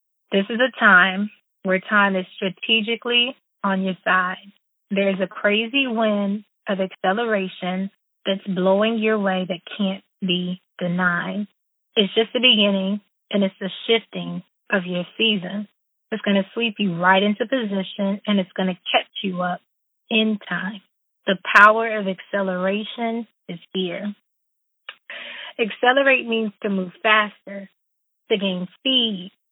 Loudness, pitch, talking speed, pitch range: -21 LUFS, 200 Hz, 135 wpm, 190-220 Hz